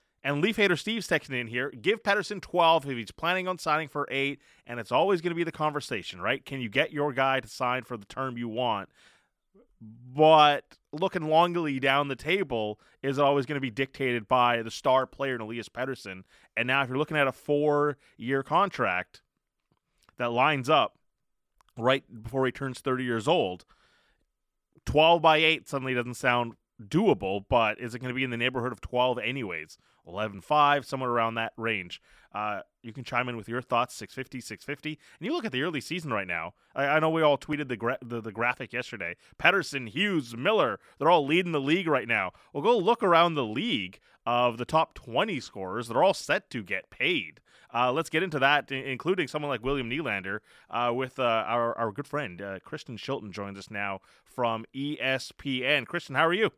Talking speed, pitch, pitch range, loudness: 200 wpm, 130 Hz, 120-150 Hz, -27 LUFS